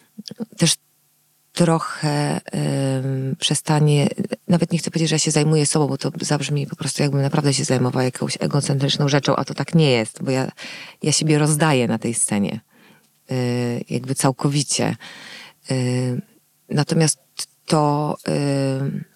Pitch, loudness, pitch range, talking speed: 145 Hz, -20 LUFS, 135-160 Hz, 140 wpm